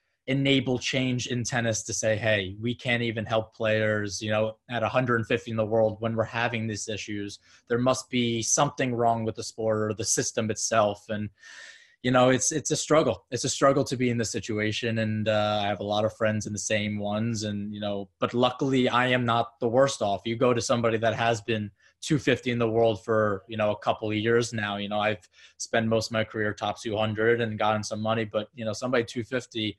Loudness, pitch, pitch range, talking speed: -26 LUFS, 115 Hz, 110-120 Hz, 225 wpm